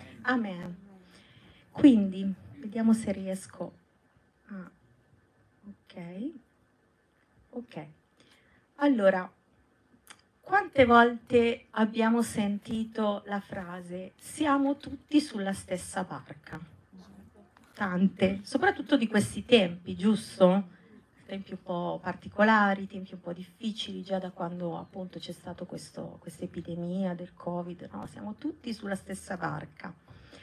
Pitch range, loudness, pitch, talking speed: 180-225 Hz, -29 LUFS, 195 Hz, 100 wpm